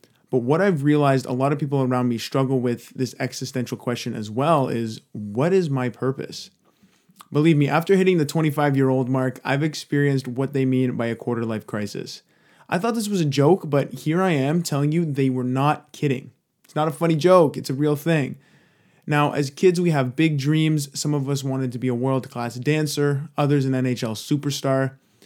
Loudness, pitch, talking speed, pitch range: -22 LUFS, 140 Hz, 205 wpm, 130-150 Hz